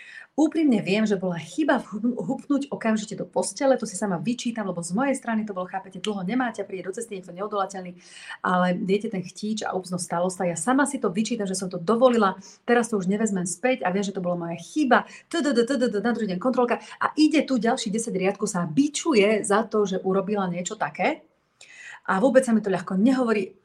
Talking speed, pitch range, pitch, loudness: 205 wpm, 190-245 Hz, 210 Hz, -24 LUFS